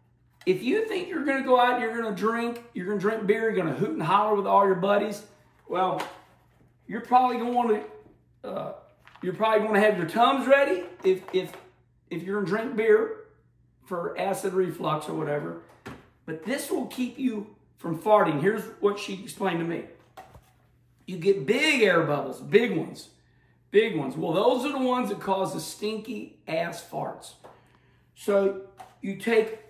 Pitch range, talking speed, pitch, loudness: 195-250 Hz, 185 wpm, 215 Hz, -26 LUFS